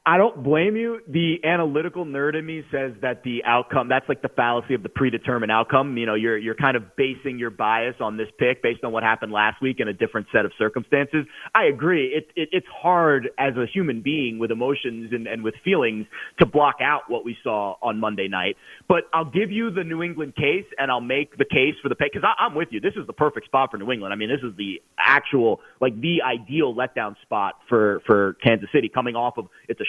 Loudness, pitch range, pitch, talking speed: -22 LUFS, 115-150 Hz, 130 Hz, 235 wpm